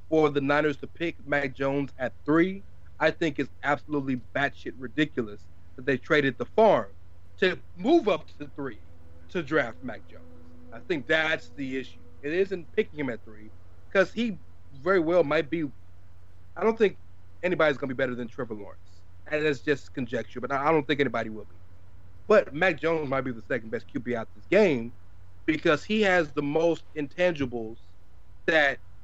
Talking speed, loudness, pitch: 180 wpm, -27 LUFS, 135 Hz